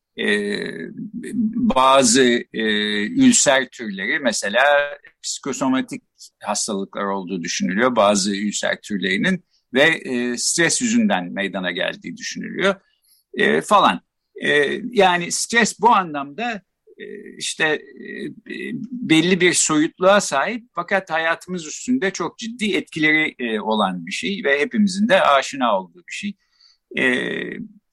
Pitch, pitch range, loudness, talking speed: 190 Hz, 145-215 Hz, -19 LUFS, 115 wpm